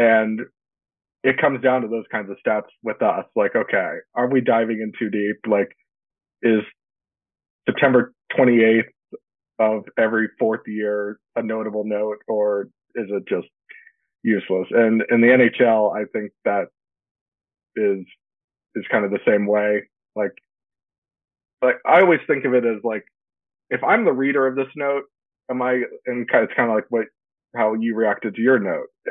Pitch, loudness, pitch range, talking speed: 115 Hz, -20 LUFS, 105-125 Hz, 165 wpm